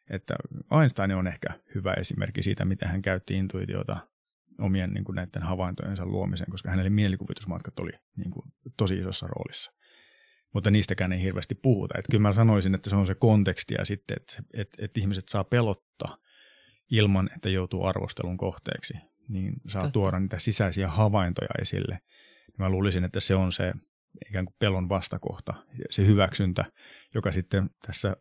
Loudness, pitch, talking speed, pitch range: -28 LUFS, 95 Hz, 160 wpm, 95-110 Hz